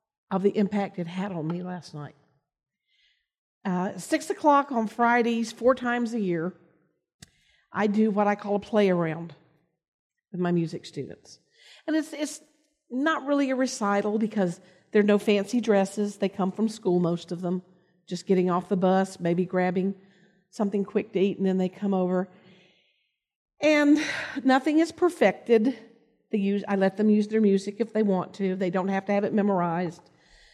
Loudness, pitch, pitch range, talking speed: -26 LUFS, 200 Hz, 185-230 Hz, 175 wpm